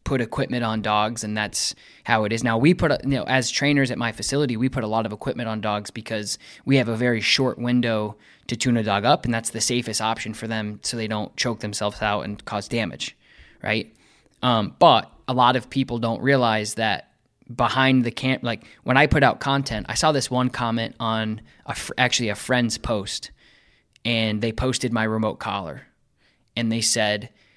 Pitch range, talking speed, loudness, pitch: 110-125 Hz, 205 wpm, -23 LUFS, 115 Hz